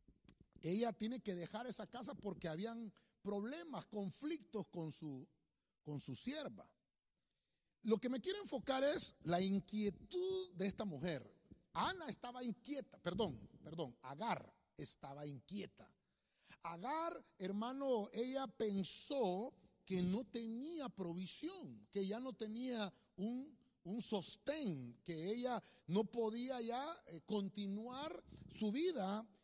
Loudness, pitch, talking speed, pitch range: -44 LUFS, 215 Hz, 115 wpm, 185-255 Hz